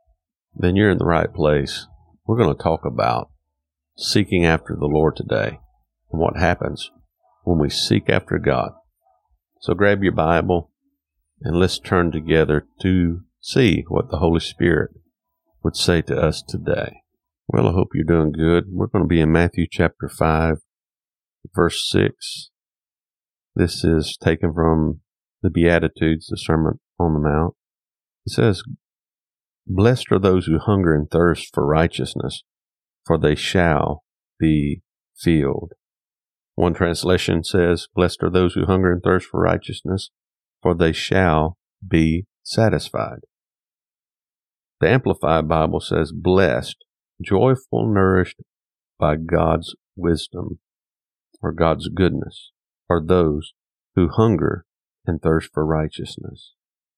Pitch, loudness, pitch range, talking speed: 85 Hz, -20 LUFS, 80-90 Hz, 130 wpm